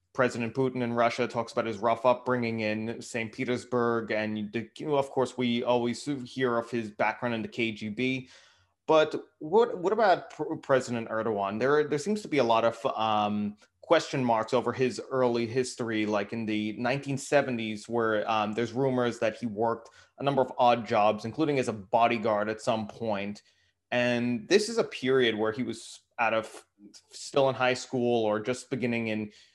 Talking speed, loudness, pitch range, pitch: 175 wpm, -28 LUFS, 110-130 Hz, 120 Hz